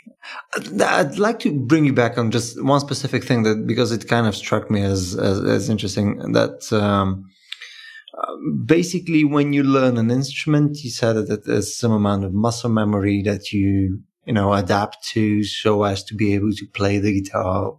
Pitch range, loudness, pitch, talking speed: 100-135 Hz, -20 LUFS, 110 Hz, 180 wpm